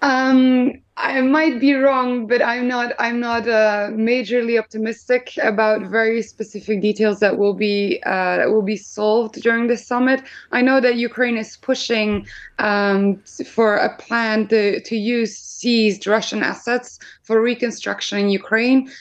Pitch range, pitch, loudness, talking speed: 215-245 Hz, 230 Hz, -18 LUFS, 150 wpm